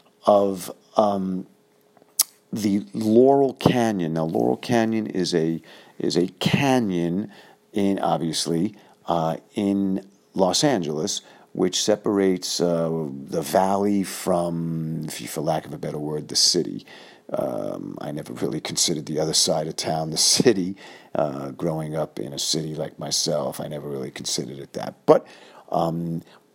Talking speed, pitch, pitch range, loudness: 140 wpm, 85 Hz, 75-100 Hz, -23 LUFS